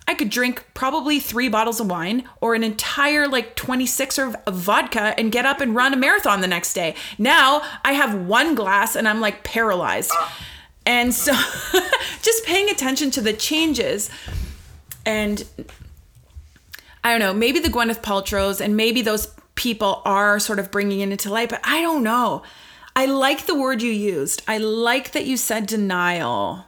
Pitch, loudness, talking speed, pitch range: 235 Hz, -20 LUFS, 175 wpm, 210-270 Hz